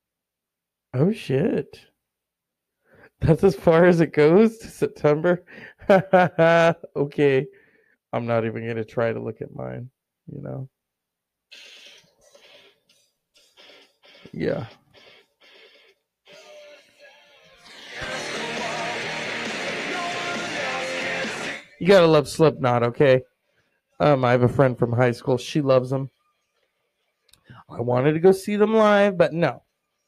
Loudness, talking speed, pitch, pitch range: -21 LUFS, 95 wpm, 150 Hz, 125-190 Hz